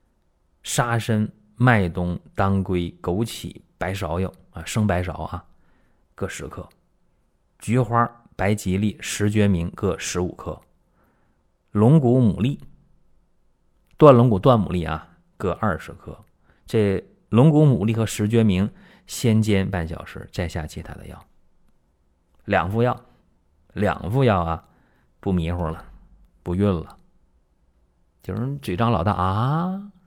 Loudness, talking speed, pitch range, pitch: -22 LUFS, 175 characters per minute, 85-110 Hz, 95 Hz